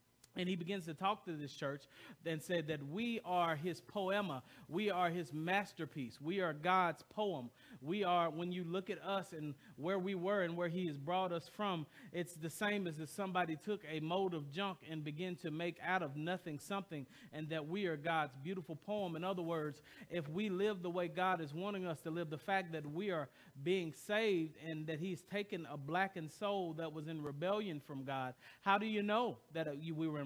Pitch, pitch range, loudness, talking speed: 175 Hz, 155-190 Hz, -41 LUFS, 215 wpm